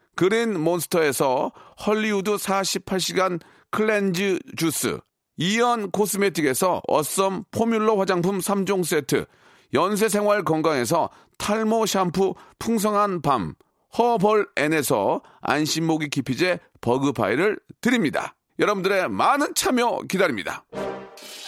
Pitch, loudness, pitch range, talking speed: 190 Hz, -23 LUFS, 160-210 Hz, 245 characters per minute